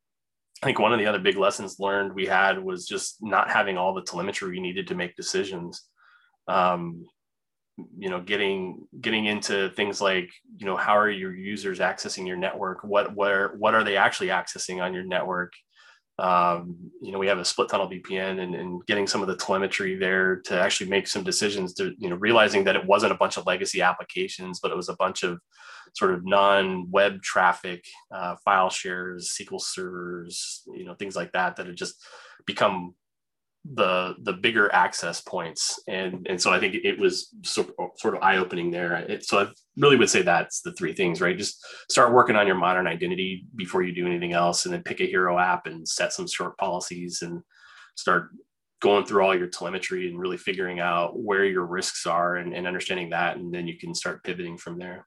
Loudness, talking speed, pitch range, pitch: -25 LUFS, 205 wpm, 90-110 Hz, 95 Hz